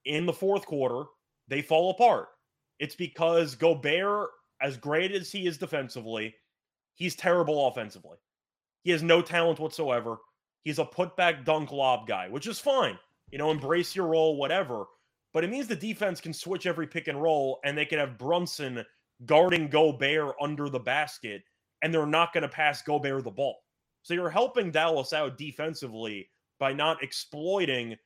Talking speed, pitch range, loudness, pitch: 165 wpm, 140-175 Hz, -28 LUFS, 155 Hz